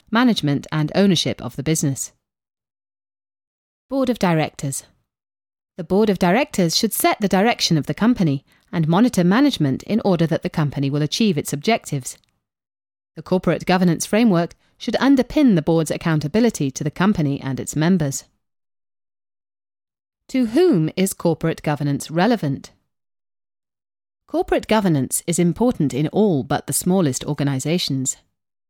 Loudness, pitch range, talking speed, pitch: -19 LUFS, 140-205 Hz, 130 wpm, 165 Hz